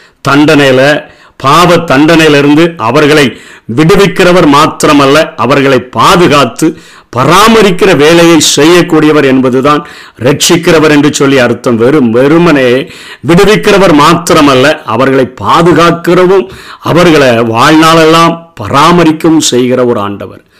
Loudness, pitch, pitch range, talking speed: -5 LUFS, 155 Hz, 135-170 Hz, 80 wpm